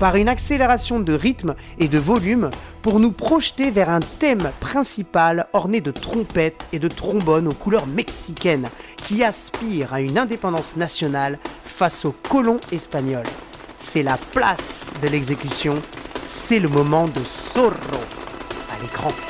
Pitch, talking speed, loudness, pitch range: 170 Hz, 145 wpm, -20 LUFS, 150-230 Hz